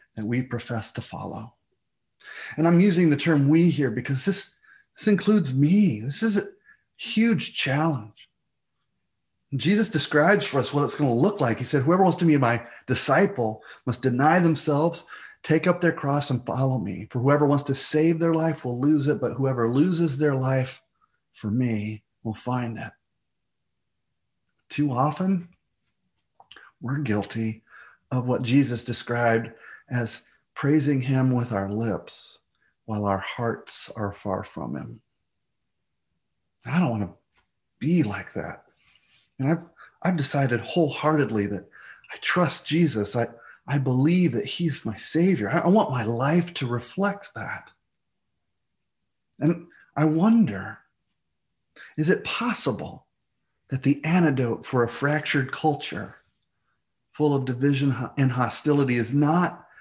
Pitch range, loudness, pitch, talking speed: 120-160 Hz, -24 LUFS, 140 Hz, 145 wpm